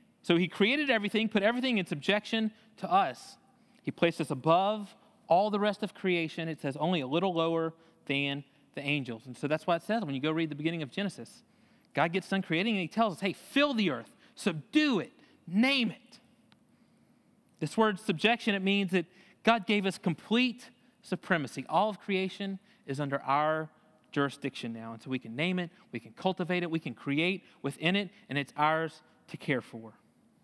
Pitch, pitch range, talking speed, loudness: 185 Hz, 155-220 Hz, 195 wpm, -31 LUFS